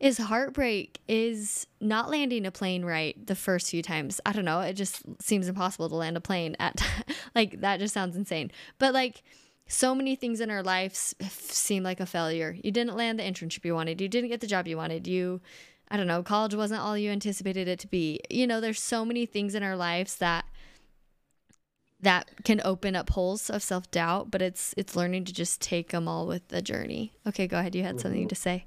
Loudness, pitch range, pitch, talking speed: -29 LUFS, 180-215 Hz, 190 Hz, 220 wpm